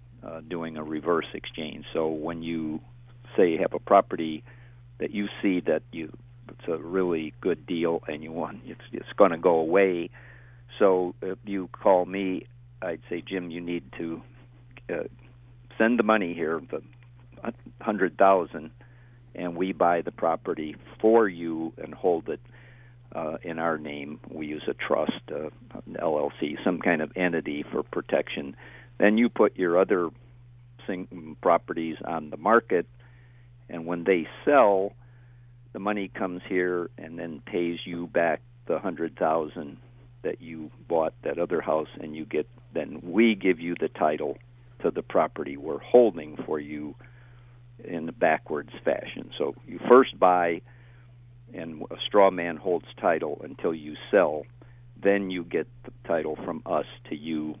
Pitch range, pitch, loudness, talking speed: 85-120 Hz, 95 Hz, -27 LUFS, 155 wpm